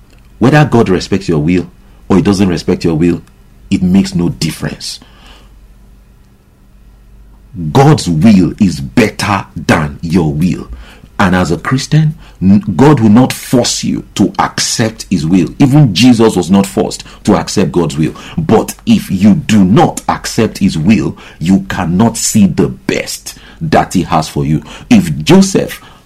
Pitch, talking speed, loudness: 100 Hz, 145 wpm, -11 LUFS